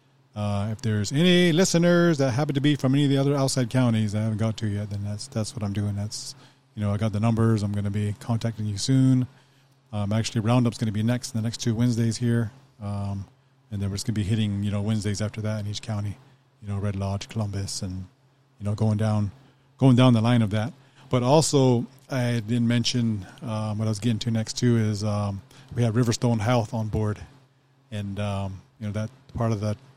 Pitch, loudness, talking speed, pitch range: 115 Hz, -25 LUFS, 235 wpm, 105-130 Hz